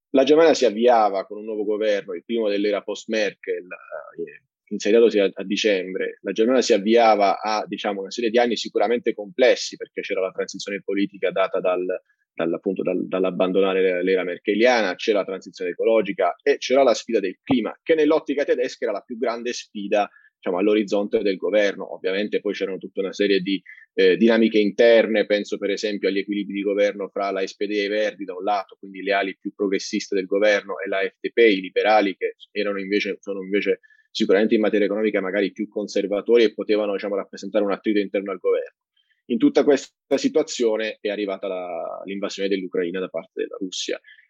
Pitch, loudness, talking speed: 105 Hz, -22 LUFS, 175 wpm